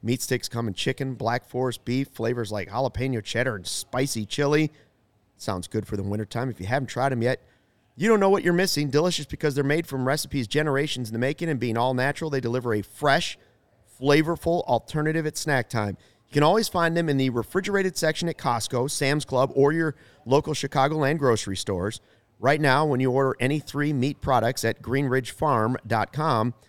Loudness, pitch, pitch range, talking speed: -25 LUFS, 130 Hz, 115-150 Hz, 195 wpm